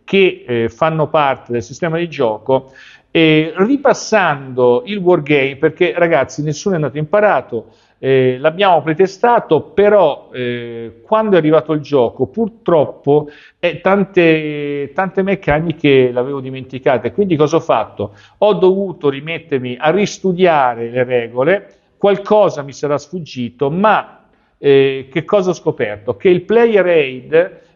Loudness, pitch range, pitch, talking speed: -14 LUFS, 135-190 Hz, 155 Hz, 130 wpm